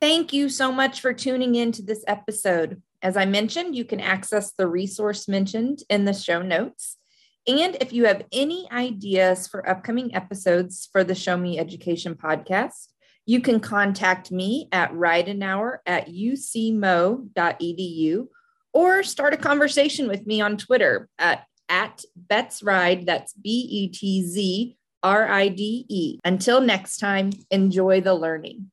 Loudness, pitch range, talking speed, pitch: -23 LUFS, 185-245 Hz, 135 wpm, 200 Hz